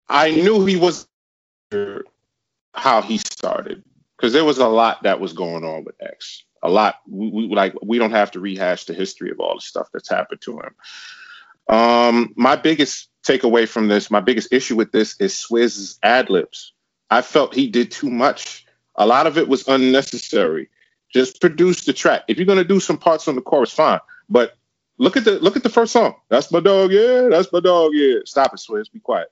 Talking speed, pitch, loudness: 205 wpm, 135 Hz, -17 LUFS